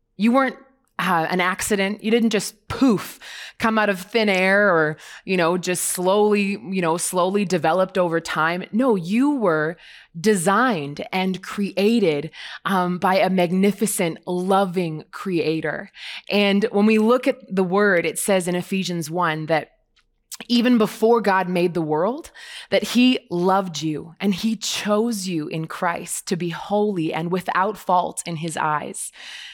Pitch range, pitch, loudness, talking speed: 175-210 Hz, 190 Hz, -21 LUFS, 150 wpm